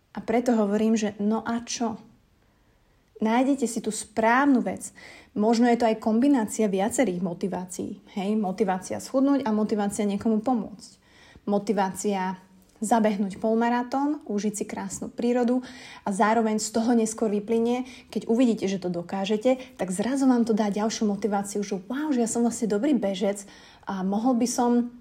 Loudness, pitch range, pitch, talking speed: -25 LUFS, 205-240 Hz, 220 Hz, 150 wpm